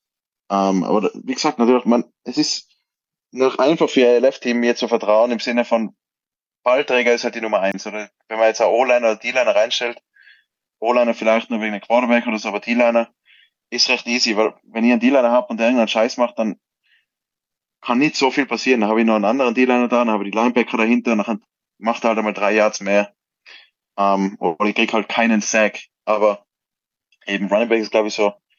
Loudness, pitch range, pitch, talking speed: -18 LUFS, 105-120 Hz, 115 Hz, 210 wpm